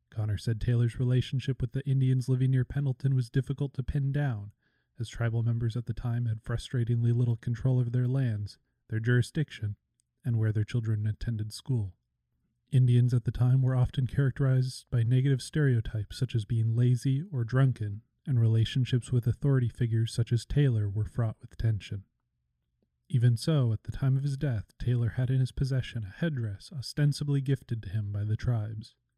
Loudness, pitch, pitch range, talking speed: -29 LUFS, 120 Hz, 110-130 Hz, 175 wpm